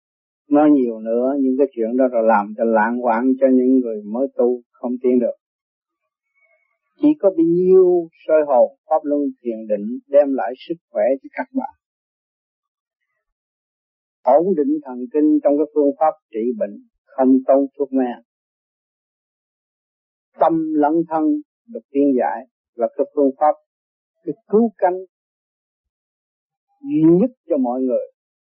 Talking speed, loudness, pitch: 145 wpm, -18 LUFS, 150 Hz